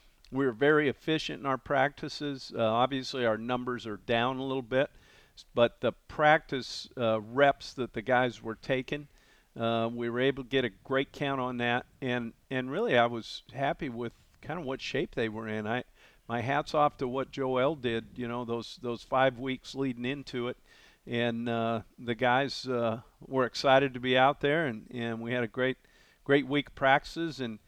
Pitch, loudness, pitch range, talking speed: 125 Hz, -30 LUFS, 115-135 Hz, 195 wpm